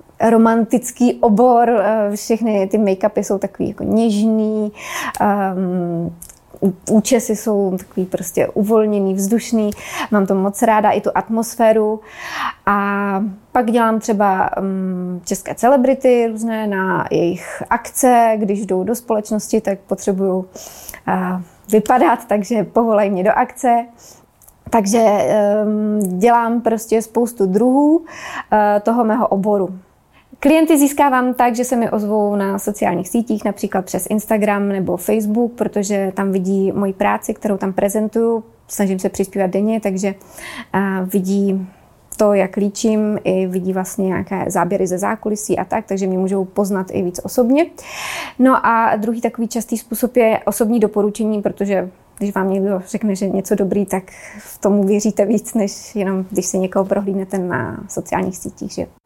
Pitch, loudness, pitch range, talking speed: 210 Hz, -17 LUFS, 195-225 Hz, 140 wpm